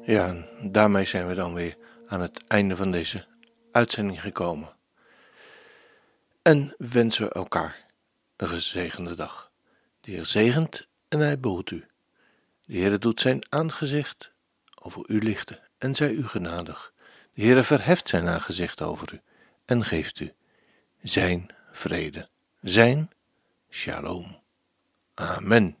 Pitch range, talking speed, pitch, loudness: 95-150 Hz, 130 wpm, 115 Hz, -25 LUFS